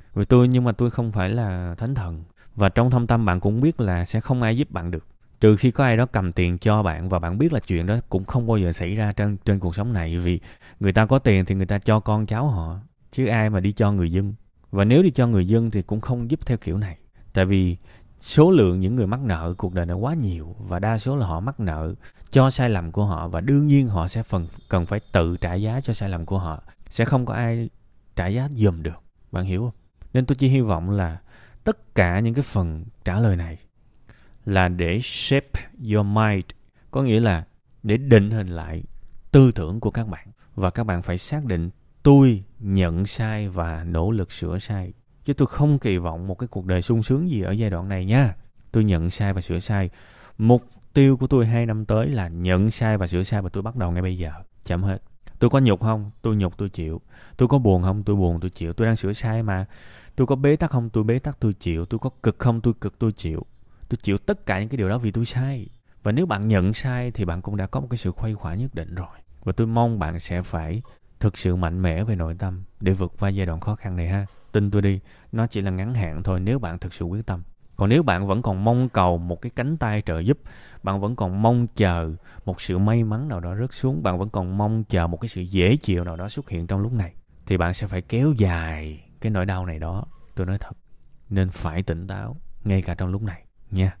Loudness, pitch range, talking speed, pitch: -23 LUFS, 90-115 Hz, 255 wpm, 100 Hz